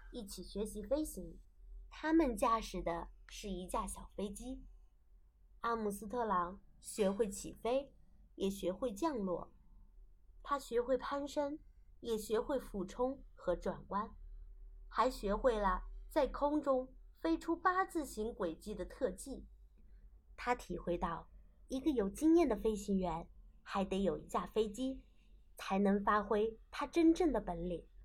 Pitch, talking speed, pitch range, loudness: 215 Hz, 195 characters per minute, 185-260 Hz, -38 LUFS